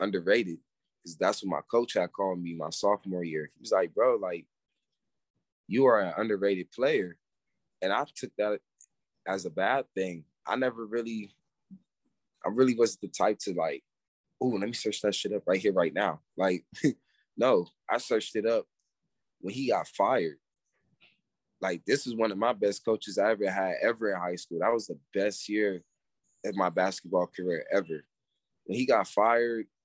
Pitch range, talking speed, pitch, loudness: 95-115 Hz, 180 wpm, 105 Hz, -29 LUFS